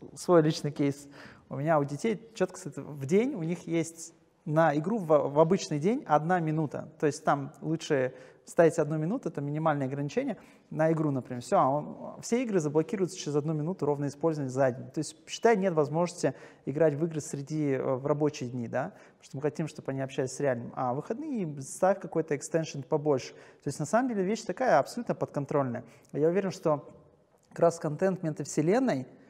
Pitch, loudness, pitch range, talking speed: 155 Hz, -30 LUFS, 145-175 Hz, 180 wpm